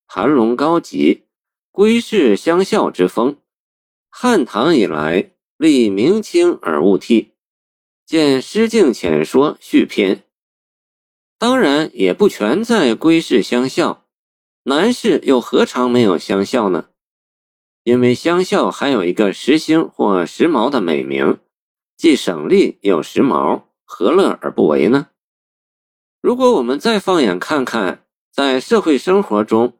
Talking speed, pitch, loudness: 180 characters per minute, 160 Hz, -15 LUFS